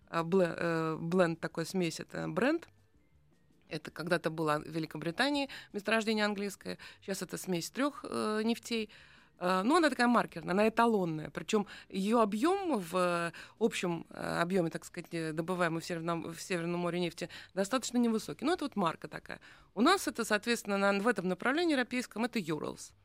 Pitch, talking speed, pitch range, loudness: 185 Hz, 145 wpm, 170-230 Hz, -33 LUFS